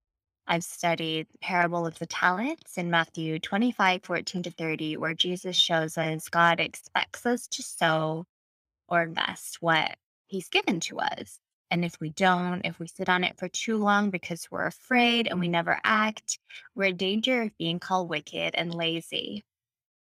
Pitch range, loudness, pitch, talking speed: 165-200 Hz, -27 LUFS, 175 Hz, 170 wpm